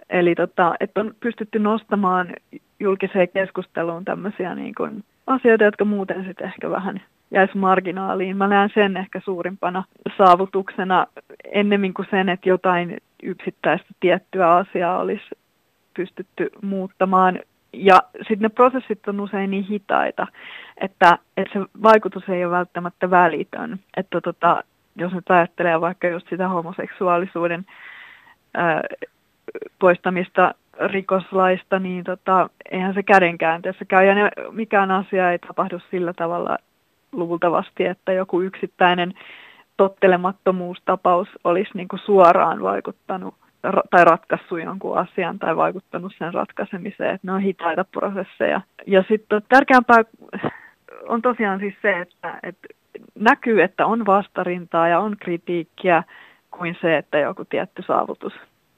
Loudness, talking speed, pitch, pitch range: -20 LUFS, 125 wpm, 190 Hz, 180-200 Hz